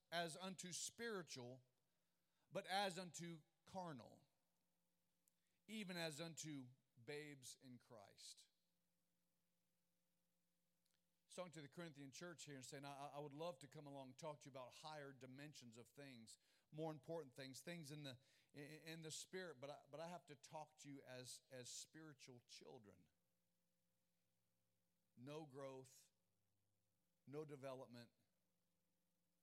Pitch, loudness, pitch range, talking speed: 150 Hz, -56 LUFS, 135-175 Hz, 125 wpm